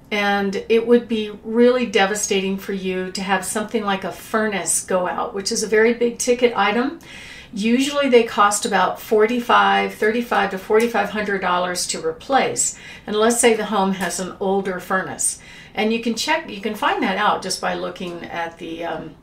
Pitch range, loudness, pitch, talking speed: 190-230 Hz, -19 LUFS, 210 Hz, 180 wpm